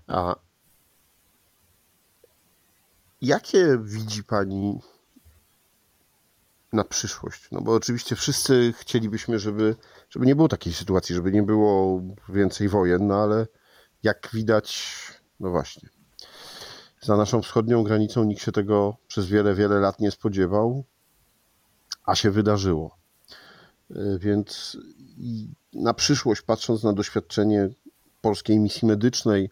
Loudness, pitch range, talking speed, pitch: -23 LUFS, 100-115 Hz, 110 wpm, 105 Hz